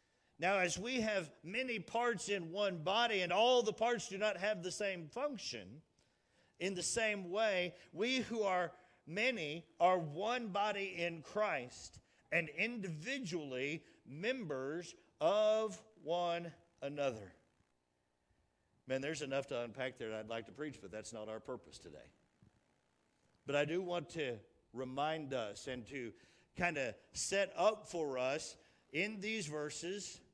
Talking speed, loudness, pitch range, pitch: 145 wpm, -39 LUFS, 135-210 Hz, 175 Hz